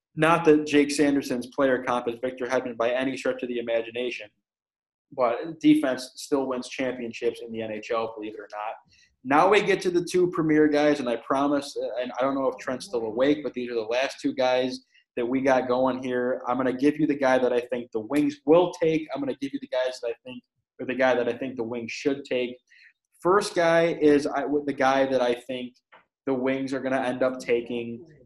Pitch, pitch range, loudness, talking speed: 130 Hz, 125-145 Hz, -25 LUFS, 230 wpm